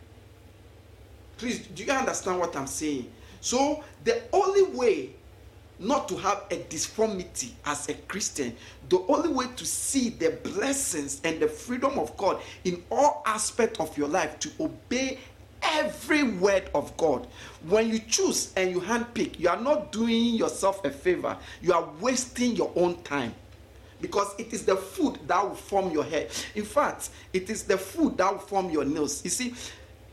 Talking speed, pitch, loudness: 170 wpm, 200 Hz, -27 LUFS